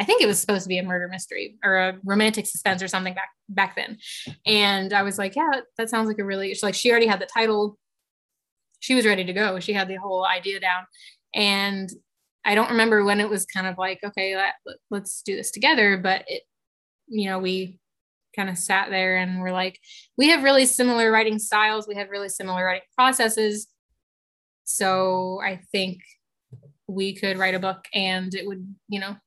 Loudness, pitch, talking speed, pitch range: -22 LUFS, 195 Hz, 205 wpm, 185-210 Hz